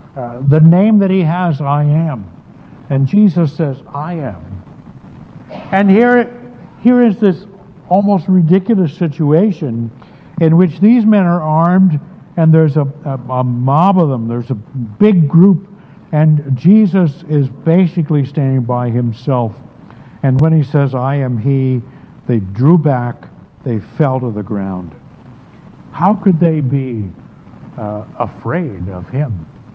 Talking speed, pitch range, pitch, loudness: 140 wpm, 125-180 Hz, 150 Hz, -13 LUFS